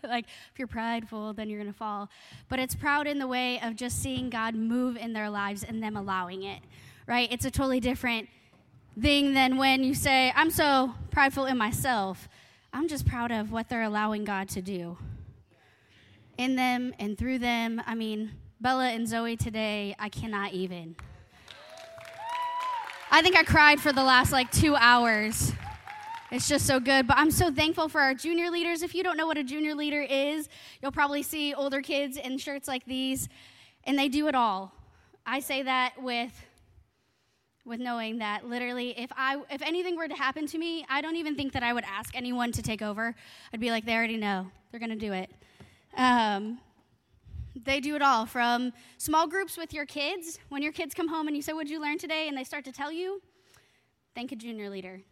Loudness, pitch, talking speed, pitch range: -28 LUFS, 255 Hz, 200 wpm, 225-295 Hz